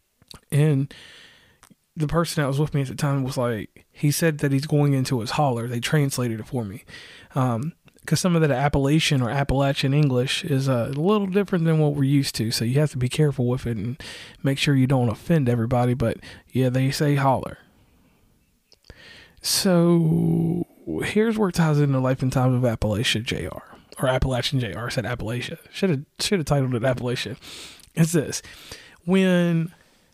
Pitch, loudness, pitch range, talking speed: 140 Hz, -23 LUFS, 125-160 Hz, 180 wpm